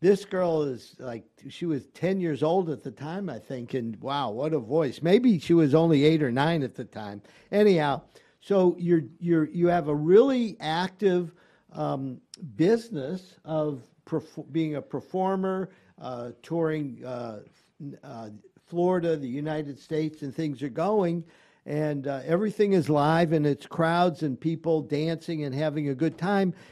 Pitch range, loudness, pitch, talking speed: 140-175 Hz, -26 LUFS, 160 Hz, 165 wpm